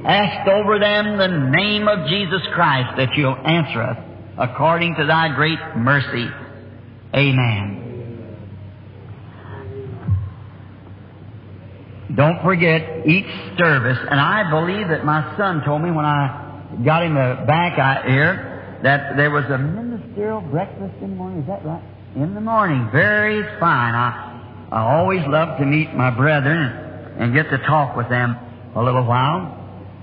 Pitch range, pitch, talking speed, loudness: 115-160 Hz, 140 Hz, 140 wpm, -18 LUFS